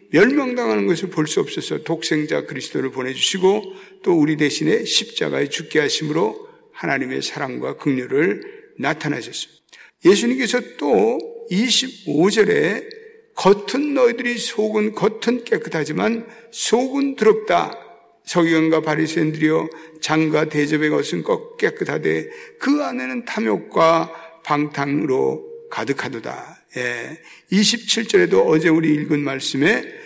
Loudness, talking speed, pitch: -19 LUFS, 275 characters per minute, 220 Hz